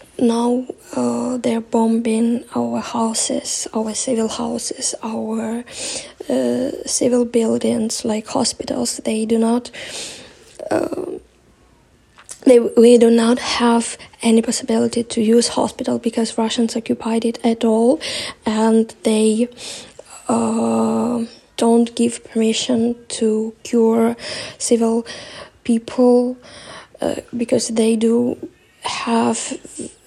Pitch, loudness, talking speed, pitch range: 235 Hz, -18 LUFS, 100 wpm, 225-245 Hz